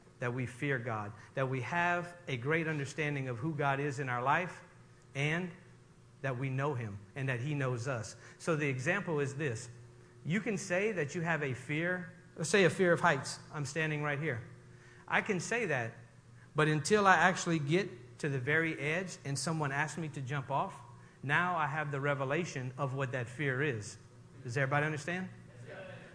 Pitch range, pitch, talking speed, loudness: 130-165 Hz, 145 Hz, 190 wpm, -34 LUFS